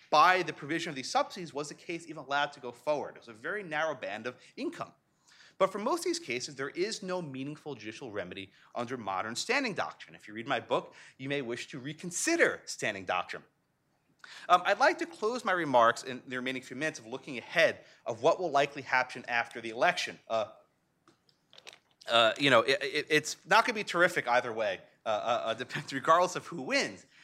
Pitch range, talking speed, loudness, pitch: 130-180 Hz, 205 wpm, -31 LUFS, 150 Hz